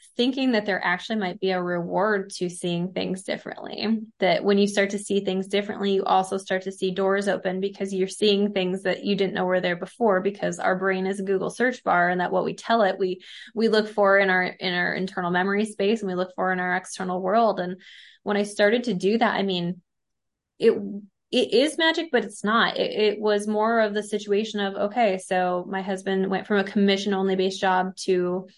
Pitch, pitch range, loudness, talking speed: 195 Hz, 185-210 Hz, -24 LUFS, 225 wpm